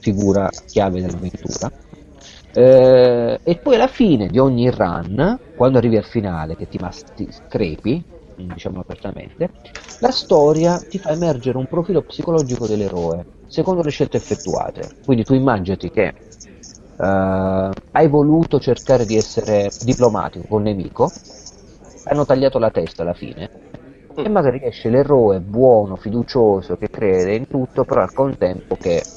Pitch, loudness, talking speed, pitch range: 120 Hz, -17 LUFS, 140 wpm, 95-140 Hz